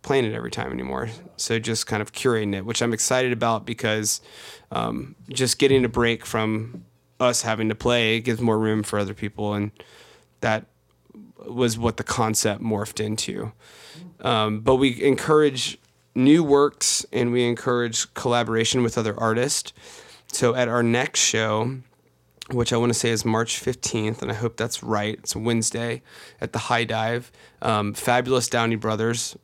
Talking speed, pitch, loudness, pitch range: 165 wpm, 115 Hz, -23 LUFS, 110-120 Hz